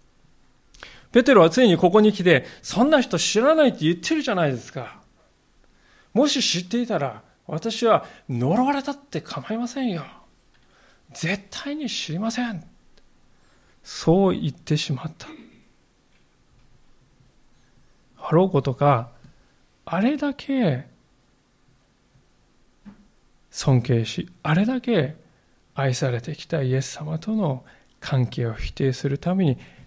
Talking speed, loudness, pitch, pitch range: 225 characters per minute, -22 LUFS, 175 Hz, 140-235 Hz